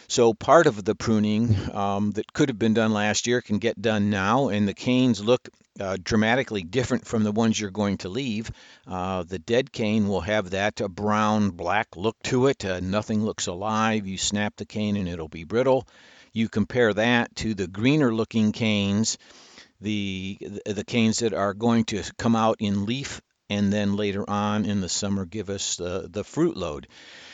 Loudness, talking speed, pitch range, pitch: -24 LUFS, 190 wpm, 100-115 Hz, 105 Hz